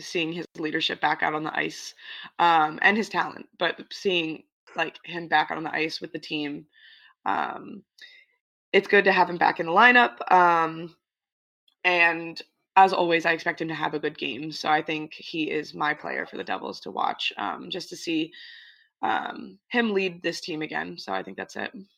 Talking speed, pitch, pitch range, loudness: 200 wpm, 170 Hz, 160-235 Hz, -25 LUFS